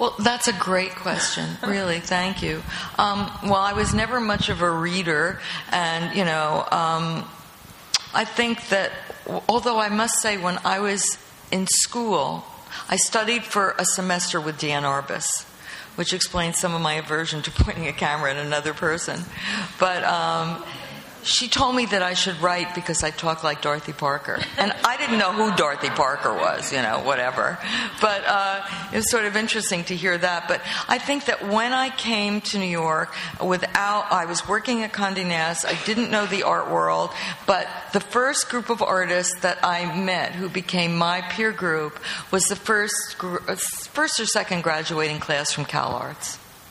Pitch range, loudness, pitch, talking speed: 165-210 Hz, -23 LUFS, 185 Hz, 175 wpm